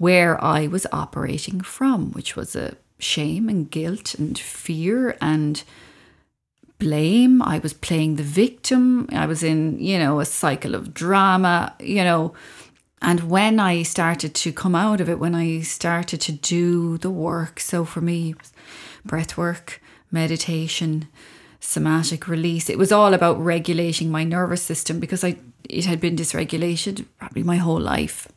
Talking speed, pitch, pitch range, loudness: 160 wpm, 170 Hz, 160-185 Hz, -21 LUFS